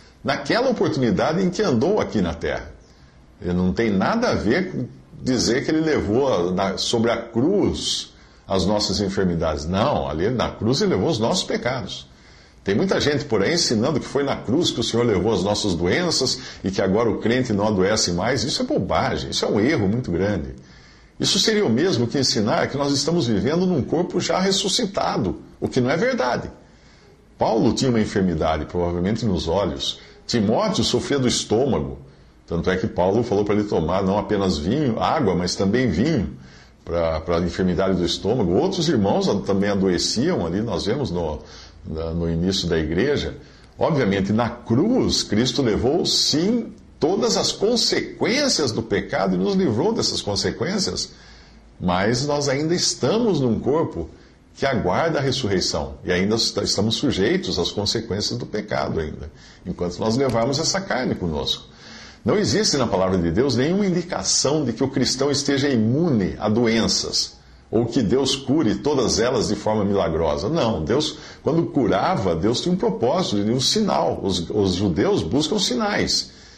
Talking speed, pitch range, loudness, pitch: 165 wpm, 85-125 Hz, -21 LUFS, 100 Hz